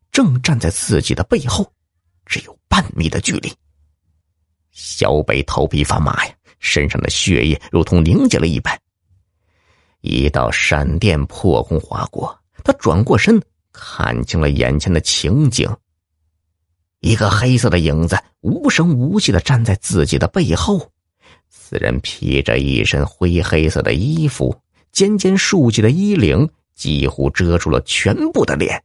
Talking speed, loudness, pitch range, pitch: 210 characters per minute, -16 LUFS, 80-115 Hz, 85 Hz